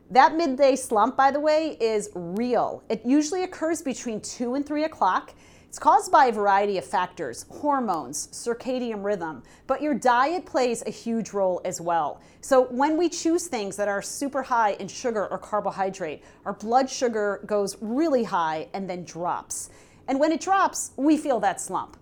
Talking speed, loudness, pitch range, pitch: 175 wpm, -25 LUFS, 205-285 Hz, 245 Hz